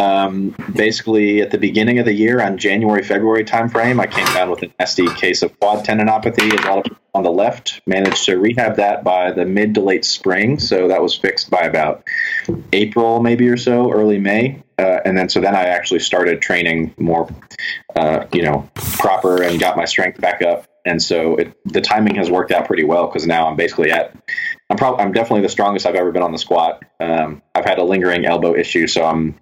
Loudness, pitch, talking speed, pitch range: -16 LUFS, 100 Hz, 220 wpm, 90-110 Hz